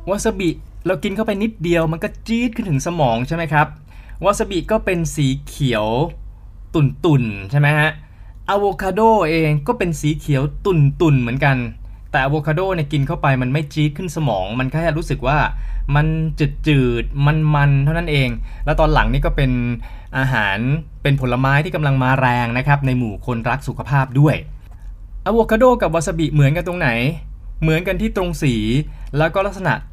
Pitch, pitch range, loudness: 150 Hz, 125-170 Hz, -18 LUFS